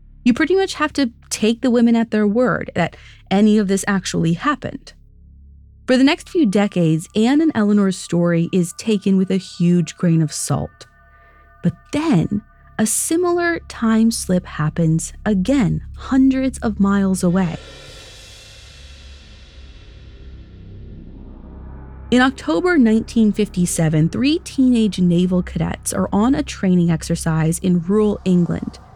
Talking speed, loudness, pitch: 125 wpm, -18 LUFS, 185 Hz